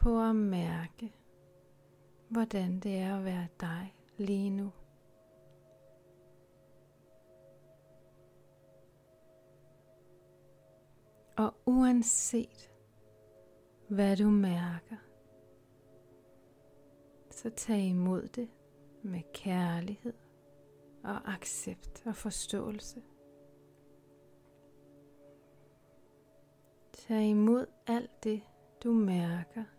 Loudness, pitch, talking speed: -33 LUFS, 145 Hz, 65 wpm